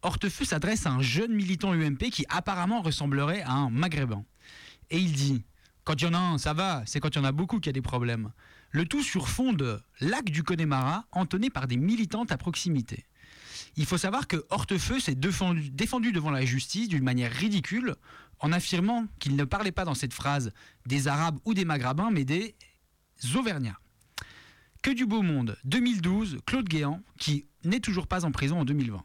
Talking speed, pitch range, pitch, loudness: 200 wpm, 140-195 Hz, 160 Hz, -29 LUFS